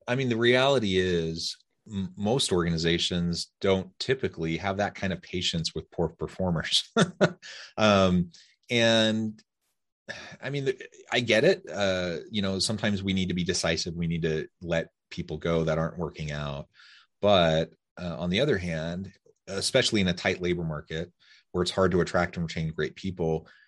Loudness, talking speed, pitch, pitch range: -27 LUFS, 160 wpm, 90 Hz, 85-100 Hz